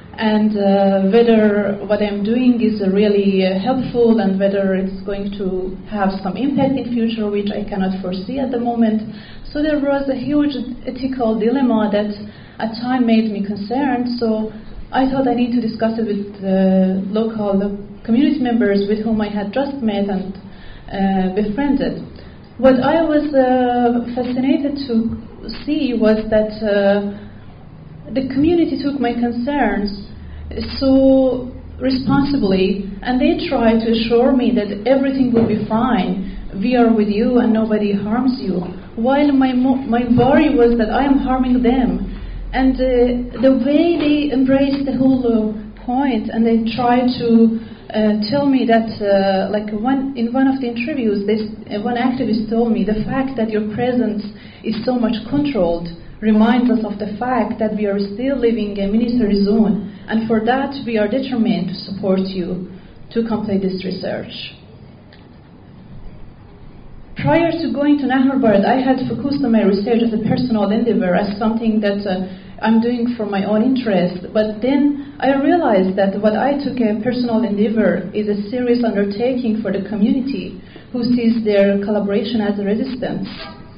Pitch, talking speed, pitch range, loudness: 225 Hz, 165 wpm, 205-255 Hz, -17 LUFS